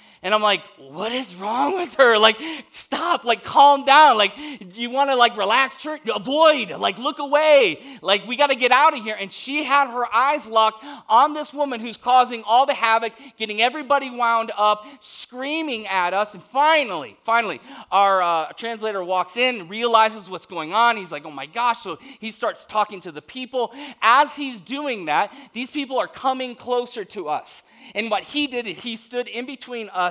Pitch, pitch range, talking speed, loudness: 245 Hz, 215-280 Hz, 190 wpm, -20 LUFS